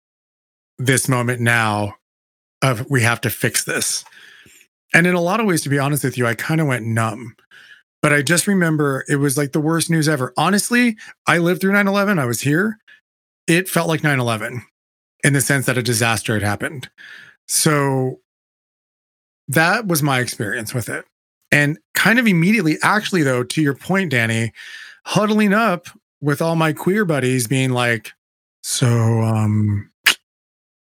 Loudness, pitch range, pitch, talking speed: -18 LUFS, 120-165 Hz, 140 Hz, 165 wpm